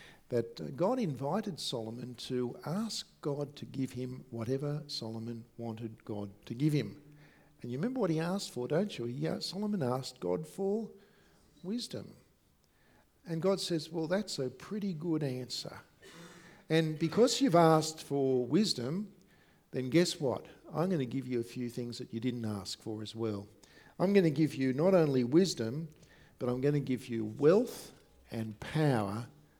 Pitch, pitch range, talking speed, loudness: 145 Hz, 120-175 Hz, 165 wpm, -34 LUFS